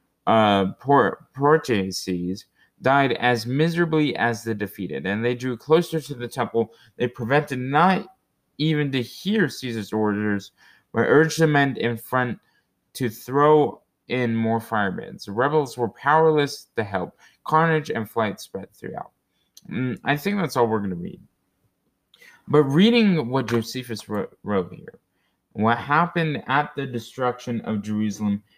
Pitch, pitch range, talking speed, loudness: 125 Hz, 110-150 Hz, 145 wpm, -22 LUFS